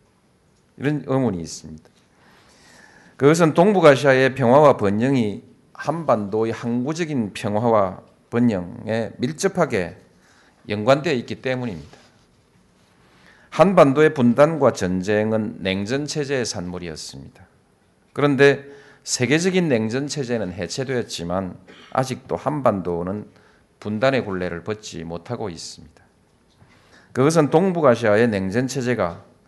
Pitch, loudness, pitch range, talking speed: 120 Hz, -20 LUFS, 100-140 Hz, 265 characters per minute